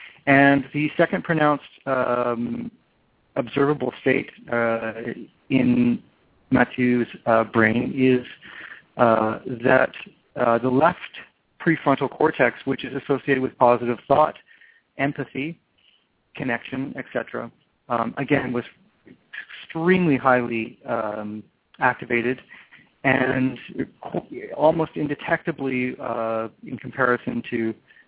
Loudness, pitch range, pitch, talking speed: -22 LUFS, 120-140 Hz, 130 Hz, 90 wpm